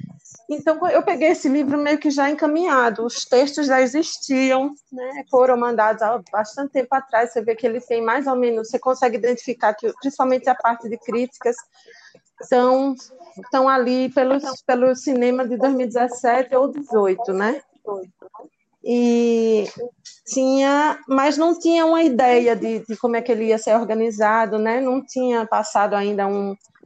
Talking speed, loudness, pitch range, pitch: 155 wpm, -19 LUFS, 230-275 Hz, 255 Hz